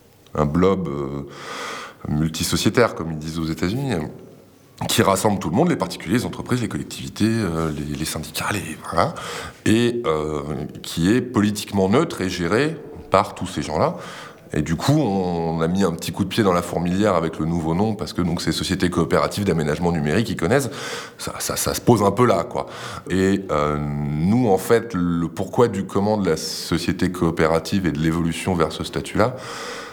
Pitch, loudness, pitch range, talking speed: 85 Hz, -21 LUFS, 80-95 Hz, 190 wpm